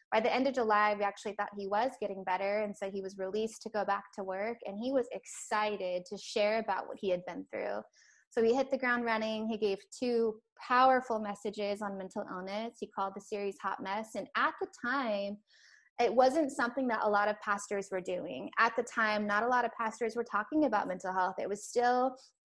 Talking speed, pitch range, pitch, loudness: 225 wpm, 200-240 Hz, 215 Hz, -33 LUFS